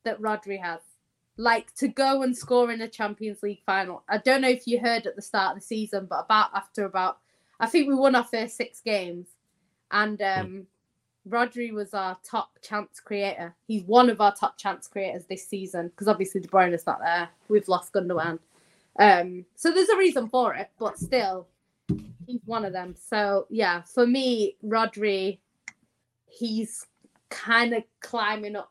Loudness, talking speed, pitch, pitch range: -26 LUFS, 180 wpm, 210 Hz, 195-235 Hz